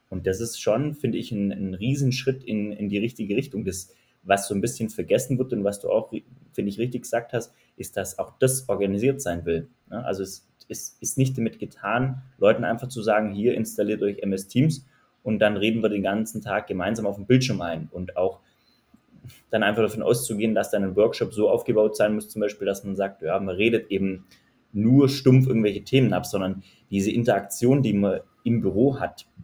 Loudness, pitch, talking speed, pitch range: -24 LUFS, 110 Hz, 205 wpm, 100-125 Hz